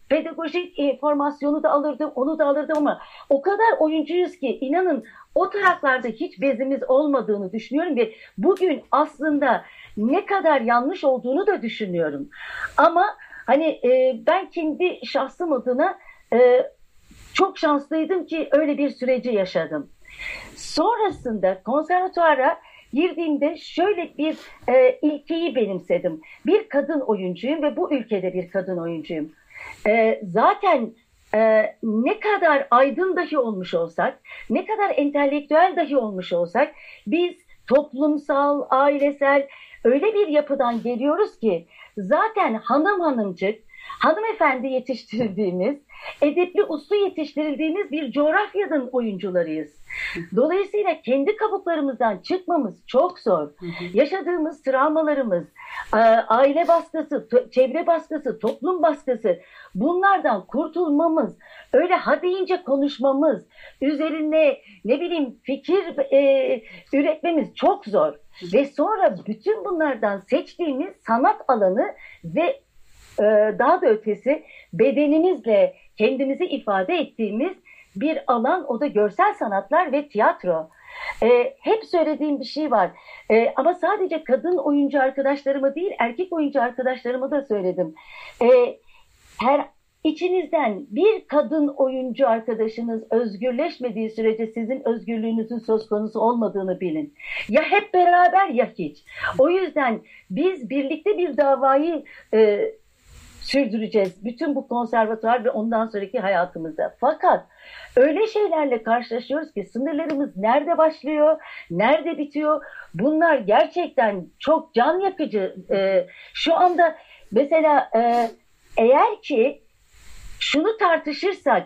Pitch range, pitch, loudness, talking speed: 235-330 Hz, 285 Hz, -21 LUFS, 110 wpm